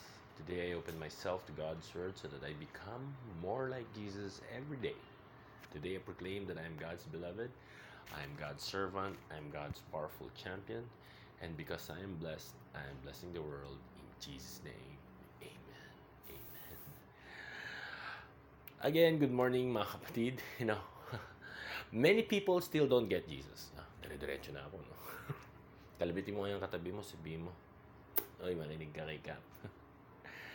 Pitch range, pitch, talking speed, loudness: 85-125 Hz, 100 Hz, 120 wpm, -41 LUFS